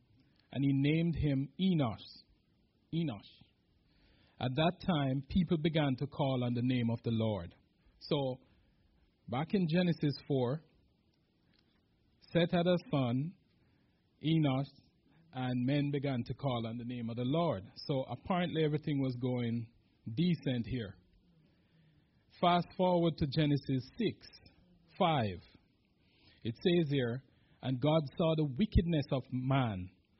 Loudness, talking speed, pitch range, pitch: -34 LUFS, 125 wpm, 120-160 Hz, 135 Hz